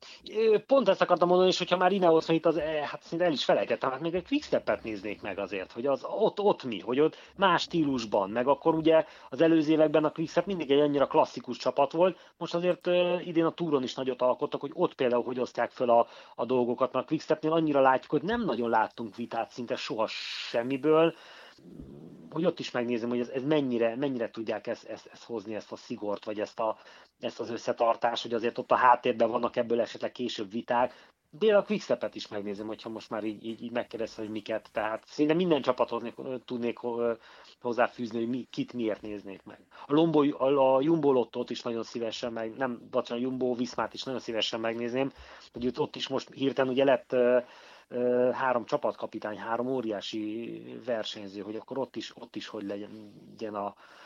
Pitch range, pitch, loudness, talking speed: 115-155 Hz, 125 Hz, -29 LUFS, 190 wpm